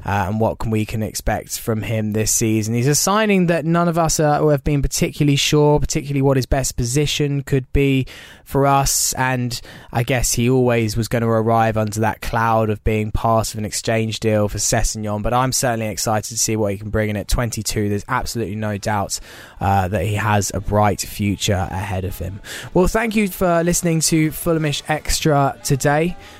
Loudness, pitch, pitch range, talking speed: -19 LUFS, 115 Hz, 105-145 Hz, 200 wpm